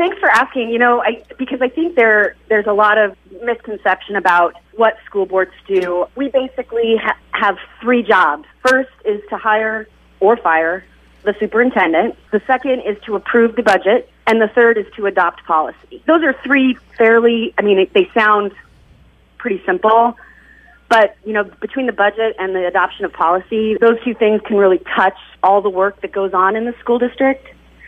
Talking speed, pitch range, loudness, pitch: 185 wpm, 200-245 Hz, -15 LUFS, 220 Hz